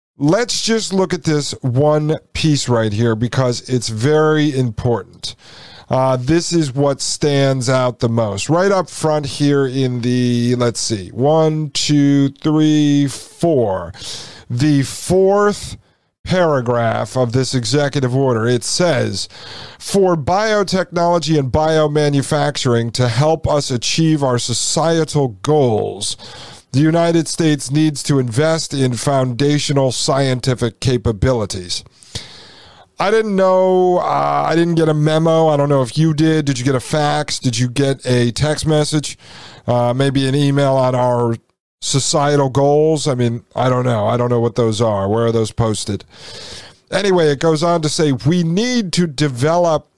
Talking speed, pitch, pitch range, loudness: 145 wpm, 140 Hz, 120-155 Hz, -16 LUFS